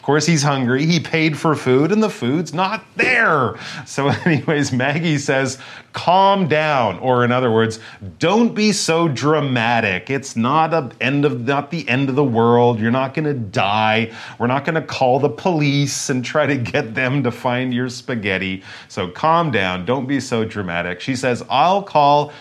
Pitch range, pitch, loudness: 120-155 Hz, 135 Hz, -18 LUFS